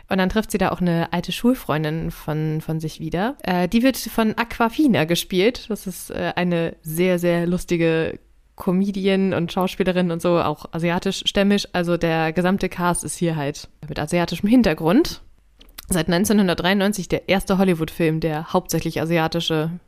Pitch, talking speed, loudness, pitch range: 175 Hz, 155 wpm, -21 LUFS, 165-195 Hz